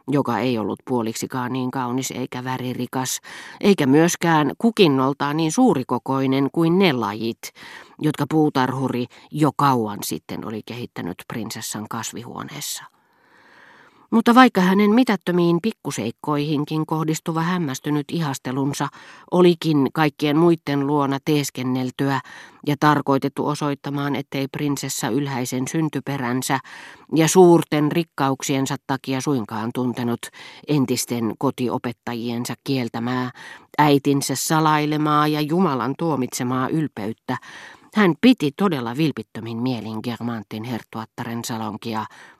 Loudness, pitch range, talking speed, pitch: -21 LUFS, 125-155 Hz, 95 wpm, 140 Hz